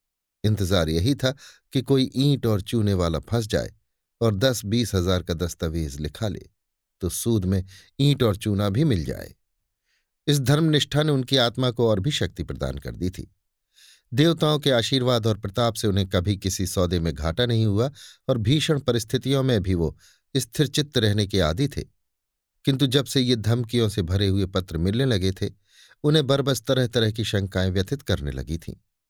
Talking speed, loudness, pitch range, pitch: 185 wpm, -23 LUFS, 95-130 Hz, 110 Hz